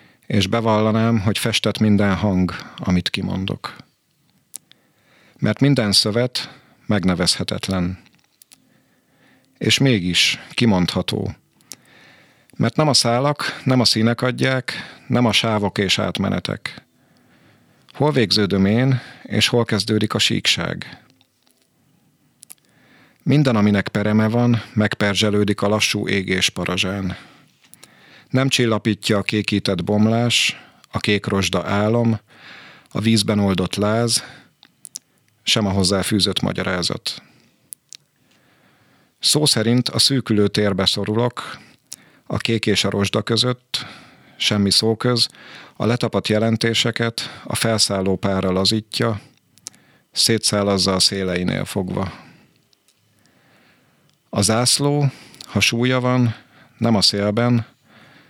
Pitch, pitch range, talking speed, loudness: 110 Hz, 100-120 Hz, 100 wpm, -18 LUFS